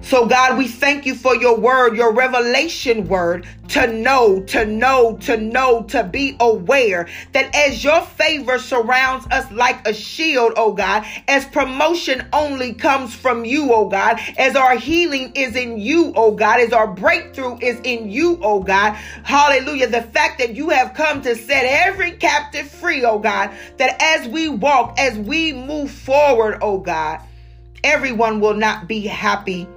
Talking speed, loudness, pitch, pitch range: 170 wpm, -16 LUFS, 255 Hz, 225-285 Hz